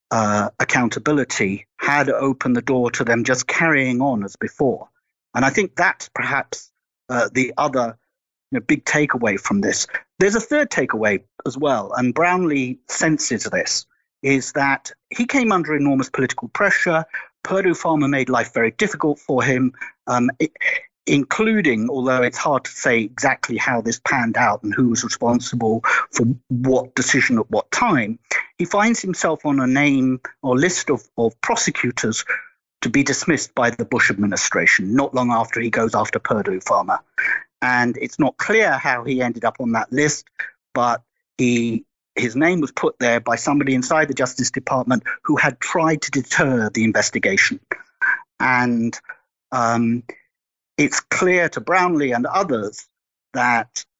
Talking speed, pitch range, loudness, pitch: 160 wpm, 120-170 Hz, -19 LUFS, 130 Hz